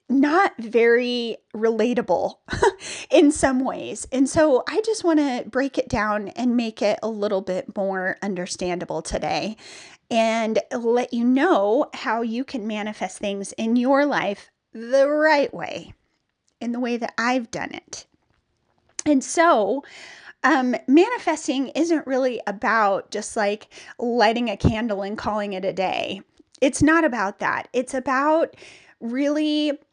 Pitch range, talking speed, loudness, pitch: 215-285 Hz, 140 wpm, -22 LUFS, 245 Hz